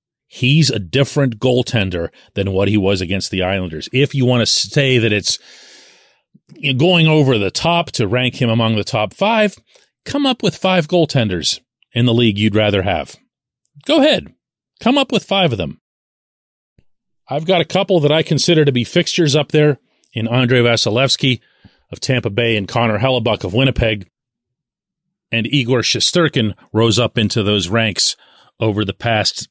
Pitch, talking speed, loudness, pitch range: 125 Hz, 165 wpm, -15 LUFS, 110-155 Hz